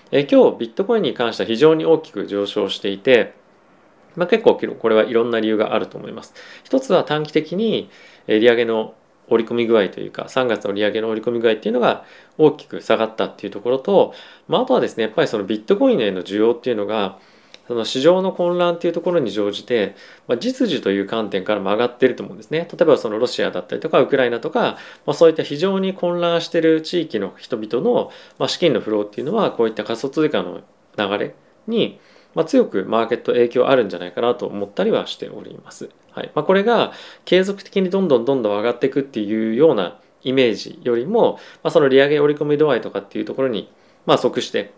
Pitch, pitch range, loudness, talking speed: 120 Hz, 110-170 Hz, -19 LUFS, 440 characters per minute